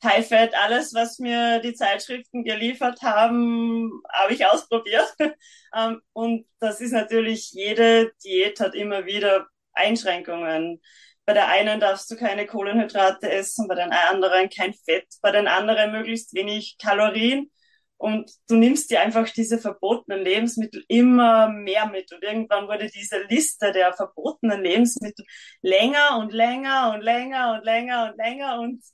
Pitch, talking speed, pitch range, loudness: 220 Hz, 145 wpm, 205-235 Hz, -22 LUFS